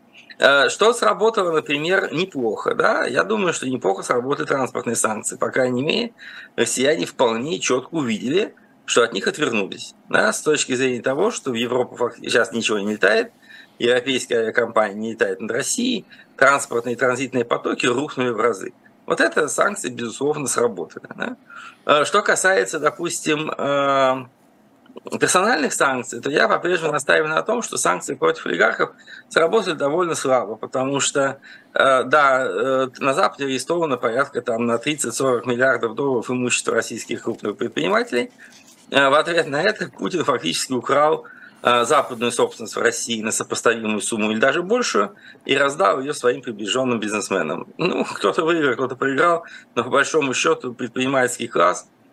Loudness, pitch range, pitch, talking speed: -20 LUFS, 120-160 Hz, 130 Hz, 140 wpm